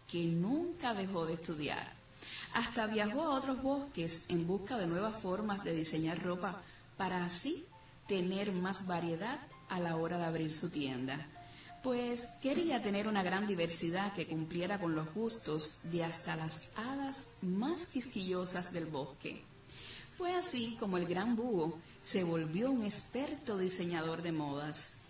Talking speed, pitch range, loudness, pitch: 150 wpm, 165-230 Hz, -36 LUFS, 180 Hz